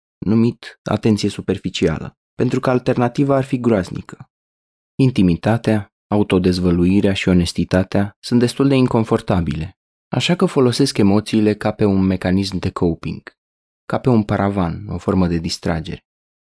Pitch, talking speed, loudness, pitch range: 105 Hz, 125 wpm, -18 LUFS, 90-120 Hz